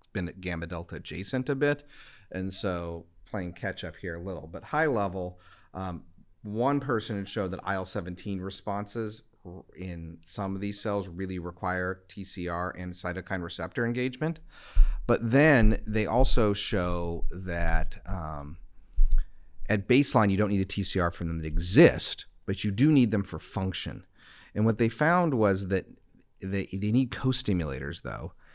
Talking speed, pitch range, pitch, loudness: 155 wpm, 90-110 Hz, 95 Hz, -29 LUFS